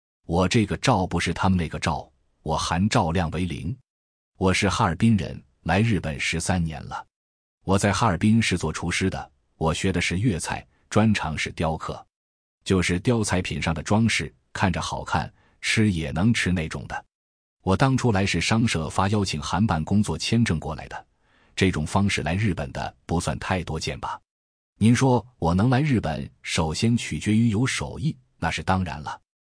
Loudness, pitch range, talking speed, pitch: -24 LUFS, 80-110 Hz, 250 characters per minute, 95 Hz